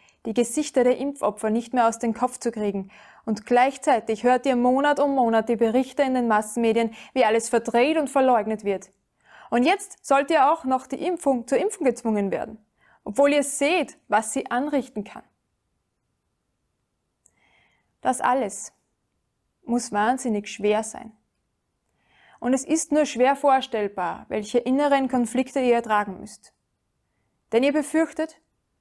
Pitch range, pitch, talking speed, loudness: 225-275 Hz, 250 Hz, 145 wpm, -23 LUFS